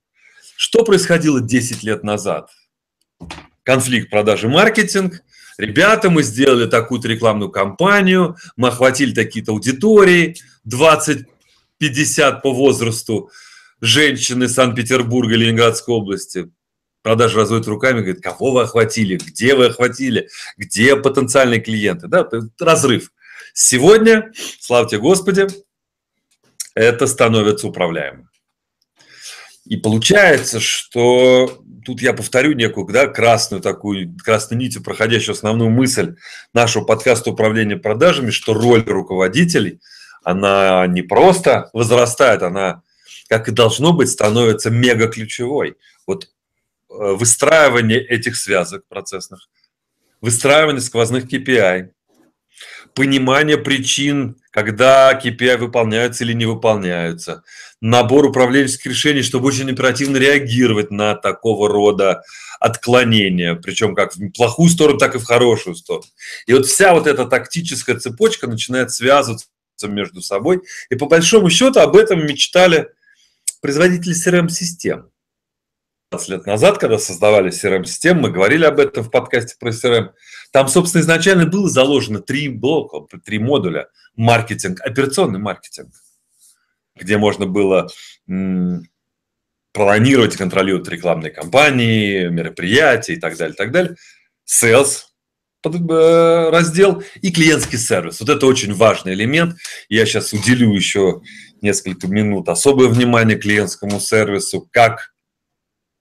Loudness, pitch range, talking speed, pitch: -14 LUFS, 110-145 Hz, 115 wpm, 120 Hz